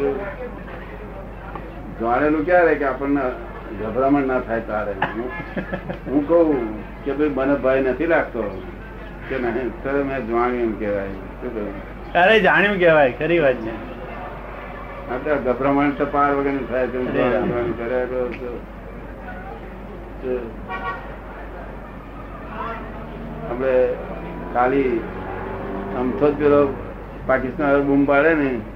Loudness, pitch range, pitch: -20 LUFS, 115-140 Hz, 130 Hz